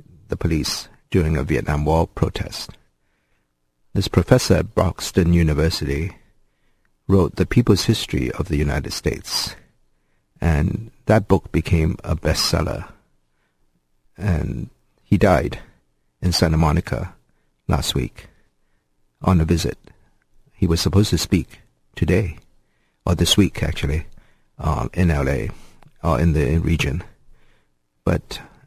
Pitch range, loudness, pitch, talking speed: 70-90 Hz, -20 LUFS, 80 Hz, 120 wpm